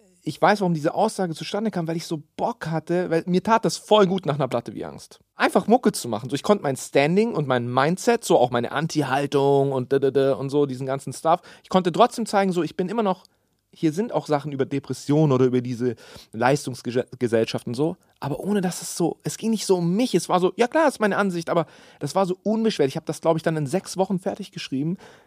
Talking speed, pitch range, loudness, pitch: 245 wpm, 140-195 Hz, -23 LUFS, 165 Hz